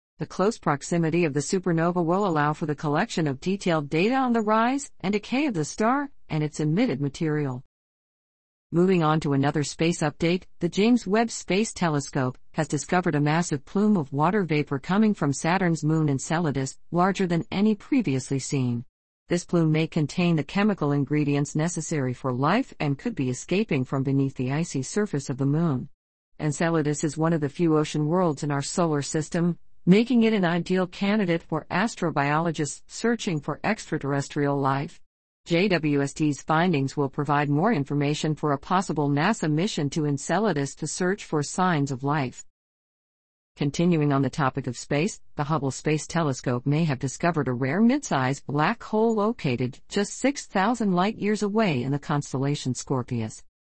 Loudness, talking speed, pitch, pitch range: -25 LUFS, 165 wpm, 155 Hz, 140-185 Hz